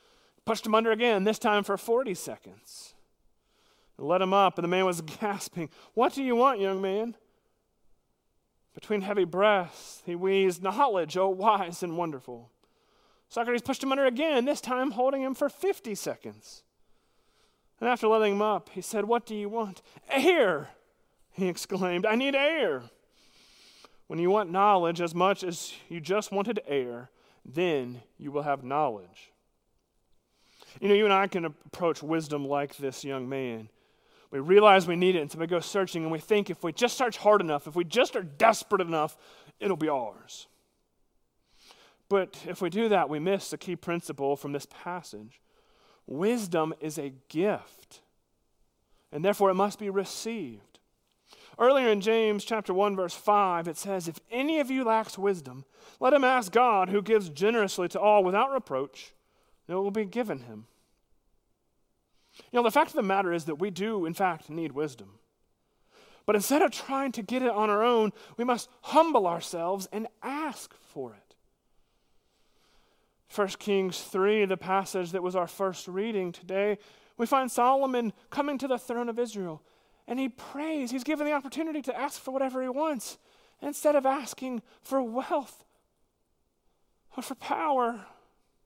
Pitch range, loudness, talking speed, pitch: 175-240 Hz, -28 LUFS, 170 wpm, 200 Hz